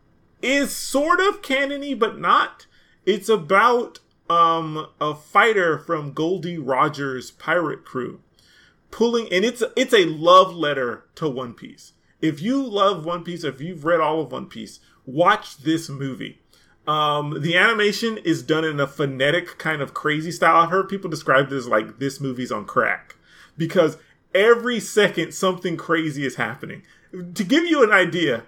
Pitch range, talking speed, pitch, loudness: 150-210 Hz, 160 wpm, 170 Hz, -20 LUFS